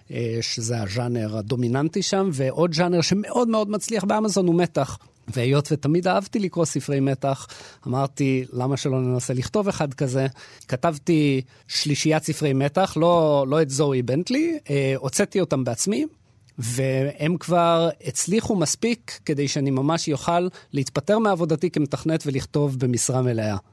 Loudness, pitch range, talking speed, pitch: -23 LUFS, 130-175 Hz, 130 wpm, 145 Hz